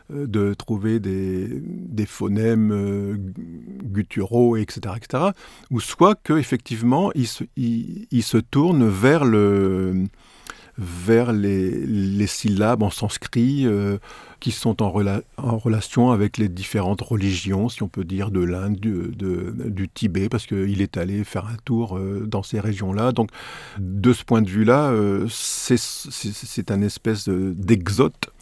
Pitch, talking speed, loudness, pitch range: 110 Hz, 150 wpm, -22 LUFS, 100-120 Hz